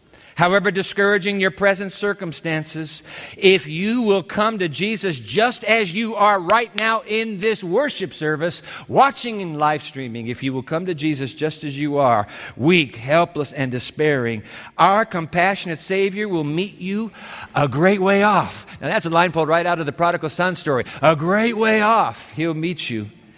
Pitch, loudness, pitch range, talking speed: 175 Hz, -19 LUFS, 155-205 Hz, 175 wpm